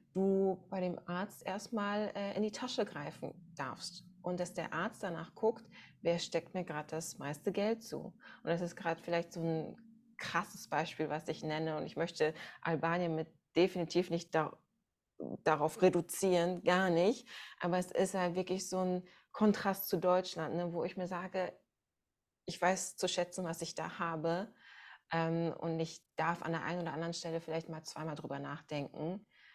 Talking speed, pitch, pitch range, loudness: 175 wpm, 175 Hz, 165-190 Hz, -37 LUFS